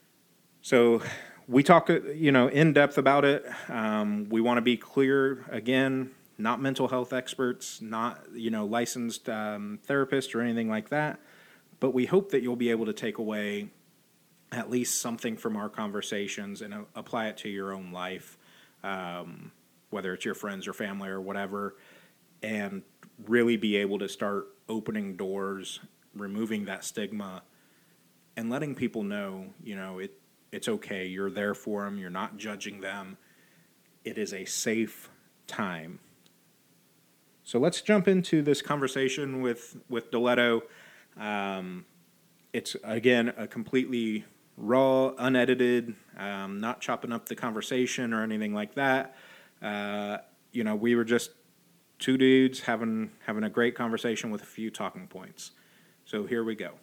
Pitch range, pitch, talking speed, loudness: 105-130 Hz, 115 Hz, 150 wpm, -29 LUFS